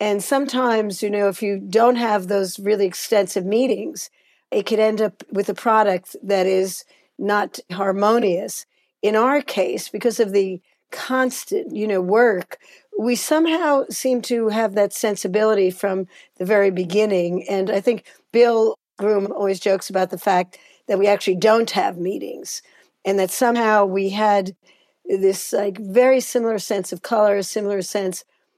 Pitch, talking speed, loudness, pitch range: 210 Hz, 155 wpm, -20 LUFS, 195-240 Hz